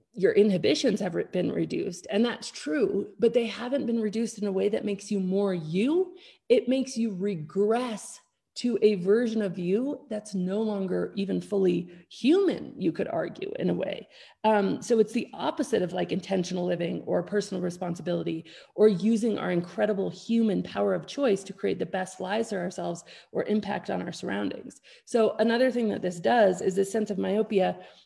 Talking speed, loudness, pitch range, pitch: 180 wpm, -27 LUFS, 185-230 Hz, 205 Hz